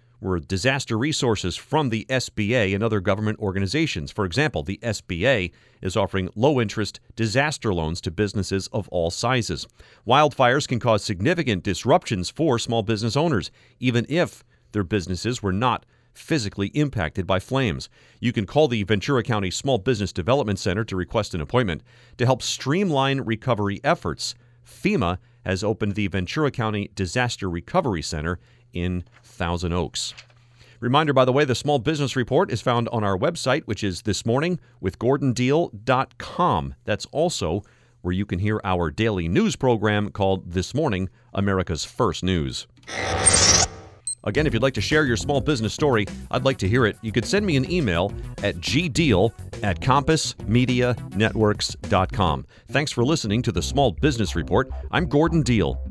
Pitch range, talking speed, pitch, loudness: 95-130 Hz, 155 wpm, 115 Hz, -23 LUFS